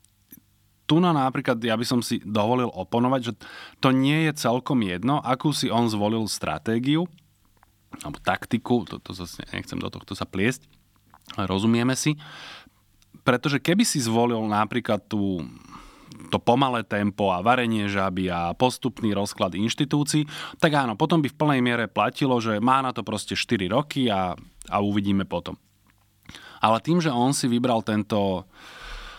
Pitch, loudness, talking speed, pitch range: 115 Hz, -24 LUFS, 155 wpm, 105-130 Hz